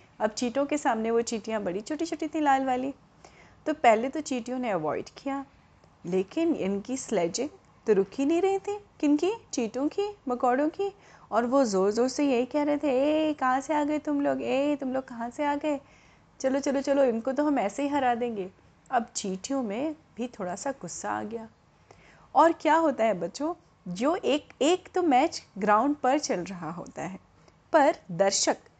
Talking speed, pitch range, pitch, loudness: 195 wpm, 225-300 Hz, 265 Hz, -28 LUFS